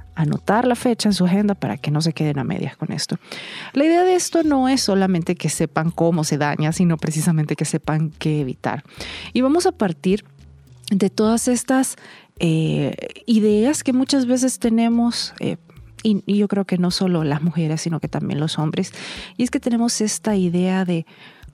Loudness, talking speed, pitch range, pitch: -20 LUFS, 190 wpm, 160-230 Hz, 185 Hz